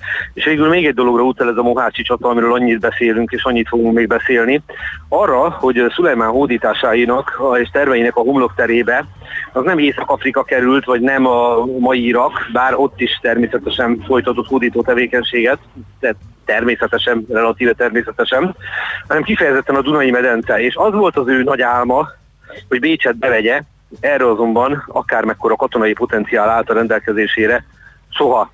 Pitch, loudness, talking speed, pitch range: 120 Hz, -14 LUFS, 150 wpm, 120-125 Hz